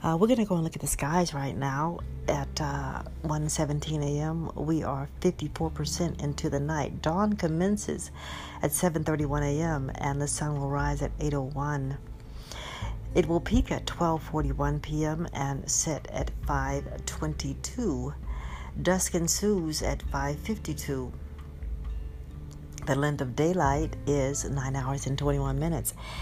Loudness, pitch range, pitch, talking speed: -30 LUFS, 110-155 Hz, 145 Hz, 130 wpm